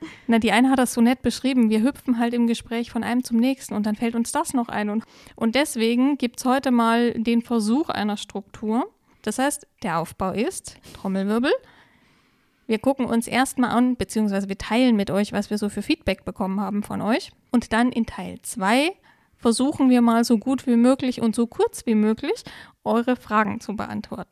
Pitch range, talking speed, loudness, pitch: 220-255 Hz, 195 wpm, -22 LUFS, 235 Hz